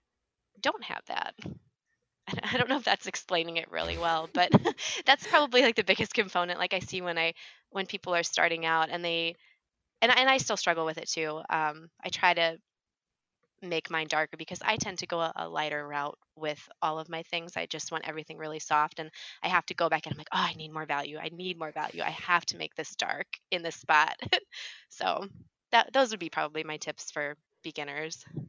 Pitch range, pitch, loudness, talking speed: 155-180 Hz, 165 Hz, -29 LUFS, 215 wpm